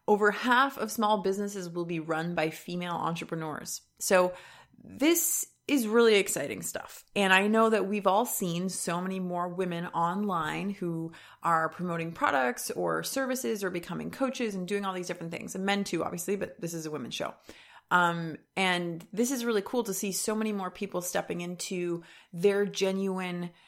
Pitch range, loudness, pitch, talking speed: 175-210 Hz, -29 LUFS, 190 Hz, 175 wpm